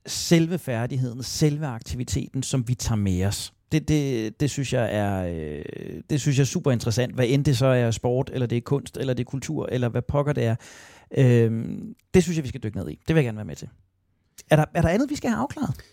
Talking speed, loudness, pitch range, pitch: 250 wpm, -24 LUFS, 115-145 Hz, 125 Hz